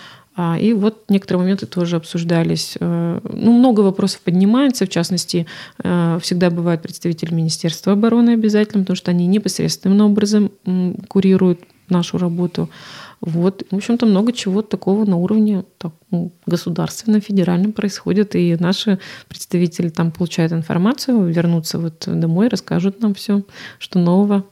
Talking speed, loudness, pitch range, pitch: 130 wpm, -17 LUFS, 175-205 Hz, 185 Hz